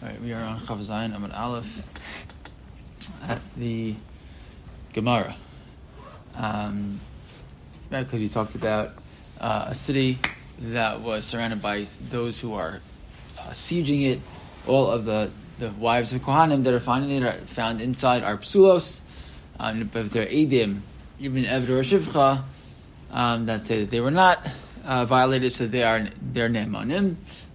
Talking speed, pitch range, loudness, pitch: 150 wpm, 105-130 Hz, -25 LUFS, 115 Hz